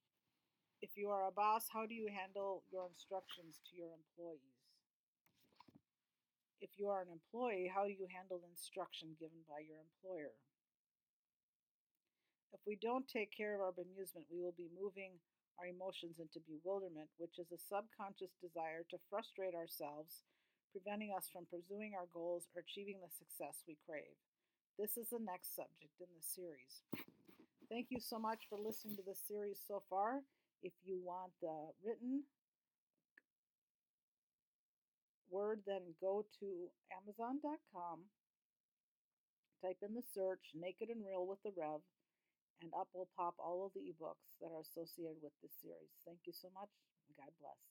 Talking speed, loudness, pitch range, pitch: 155 wpm, -48 LUFS, 165-205 Hz, 185 Hz